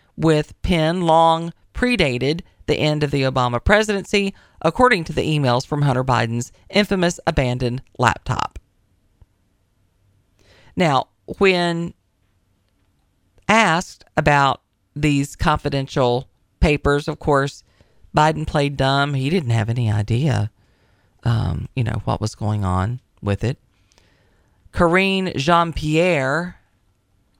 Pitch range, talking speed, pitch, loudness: 100-160 Hz, 105 wpm, 130 Hz, -19 LUFS